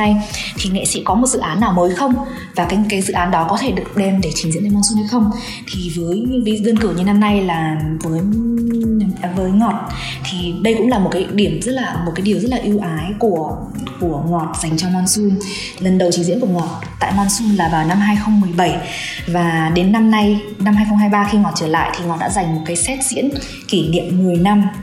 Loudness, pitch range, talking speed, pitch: -16 LUFS, 175-210 Hz, 230 wpm, 195 Hz